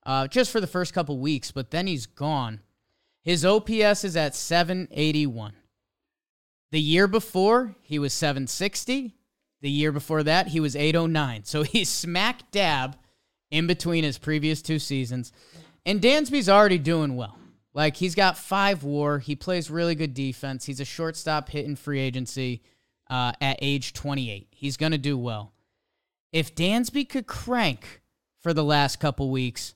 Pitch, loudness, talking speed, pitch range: 150 Hz, -25 LUFS, 155 wpm, 135-180 Hz